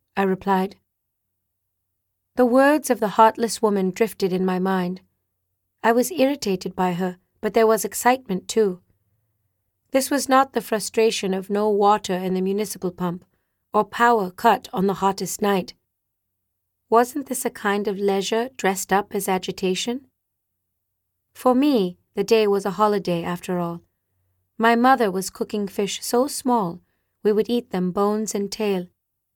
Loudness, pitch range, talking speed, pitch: -22 LUFS, 170-225 Hz, 150 wpm, 195 Hz